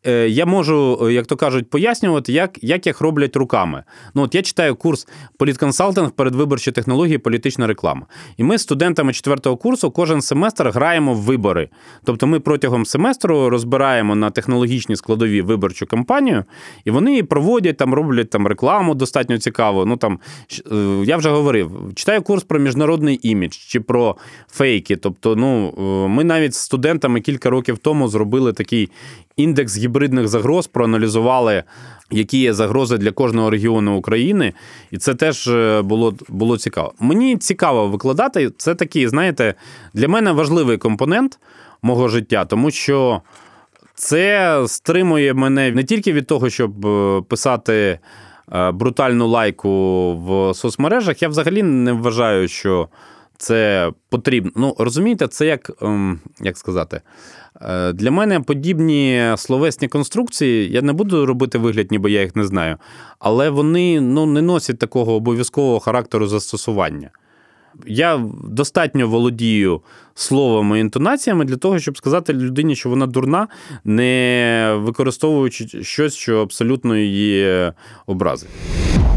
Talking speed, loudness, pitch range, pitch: 135 wpm, -17 LUFS, 110-150 Hz, 125 Hz